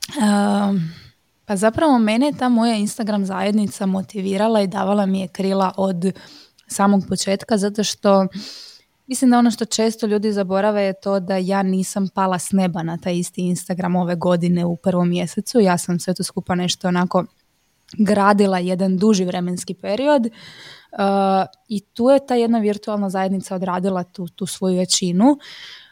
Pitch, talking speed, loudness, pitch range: 195 Hz, 160 wpm, -19 LUFS, 185-210 Hz